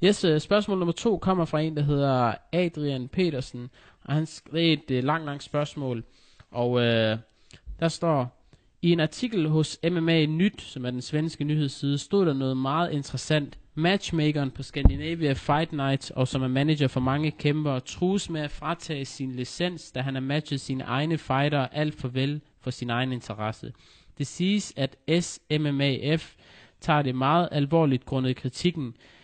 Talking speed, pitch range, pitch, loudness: 165 wpm, 130-160 Hz, 145 Hz, -27 LUFS